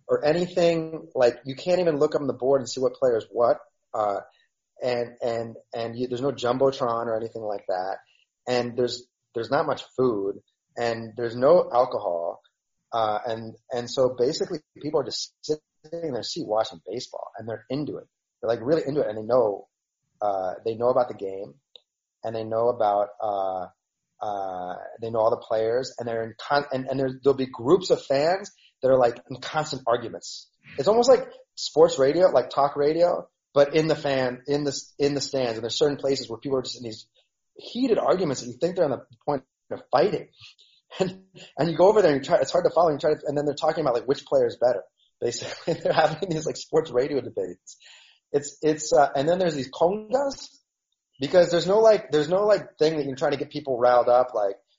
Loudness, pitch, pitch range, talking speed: -25 LUFS, 140 Hz, 120-170 Hz, 215 wpm